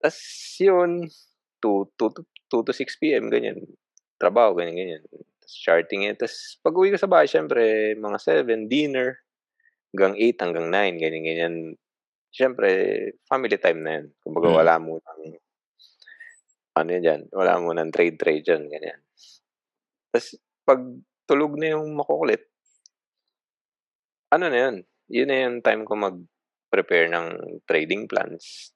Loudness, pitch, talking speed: -23 LUFS, 135 Hz, 140 wpm